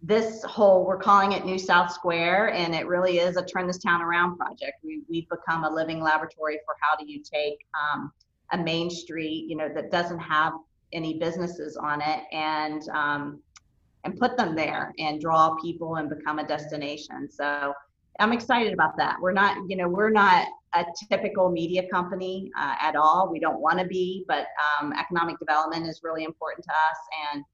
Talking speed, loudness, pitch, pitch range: 190 wpm, -25 LUFS, 165 Hz, 155-185 Hz